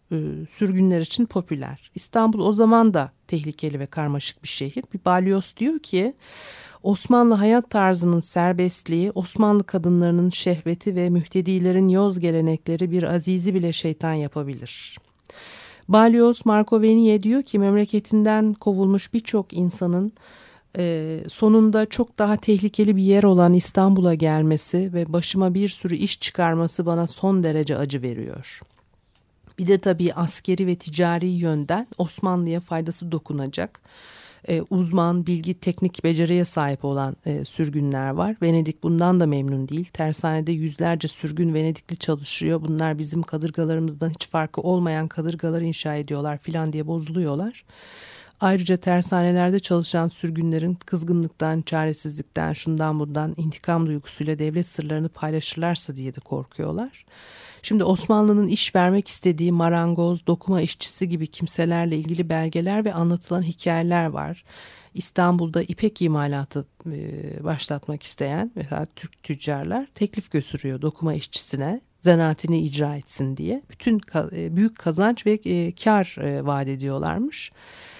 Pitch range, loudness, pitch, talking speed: 155-190 Hz, -22 LUFS, 170 Hz, 120 wpm